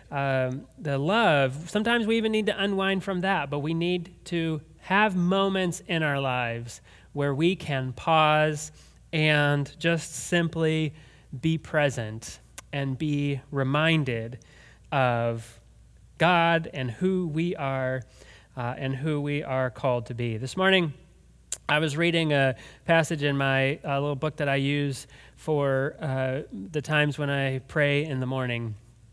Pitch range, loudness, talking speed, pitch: 130-165 Hz, -26 LUFS, 145 wpm, 145 Hz